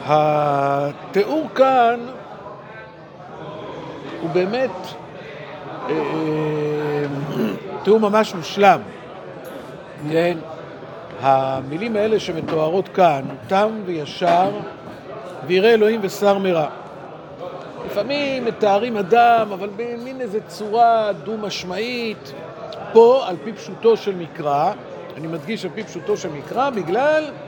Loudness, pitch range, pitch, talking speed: -19 LUFS, 160-220 Hz, 190 Hz, 85 wpm